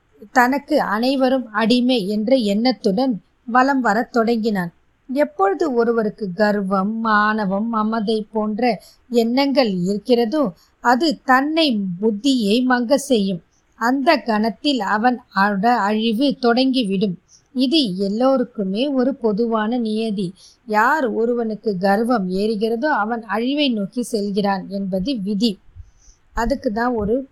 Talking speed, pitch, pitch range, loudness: 95 wpm, 230 Hz, 210-255 Hz, -19 LUFS